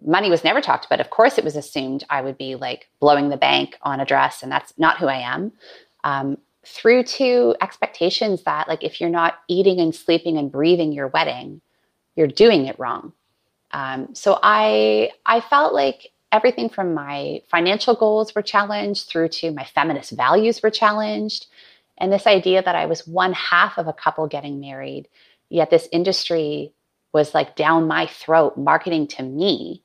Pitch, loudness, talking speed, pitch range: 165 Hz, -19 LUFS, 180 wpm, 145-200 Hz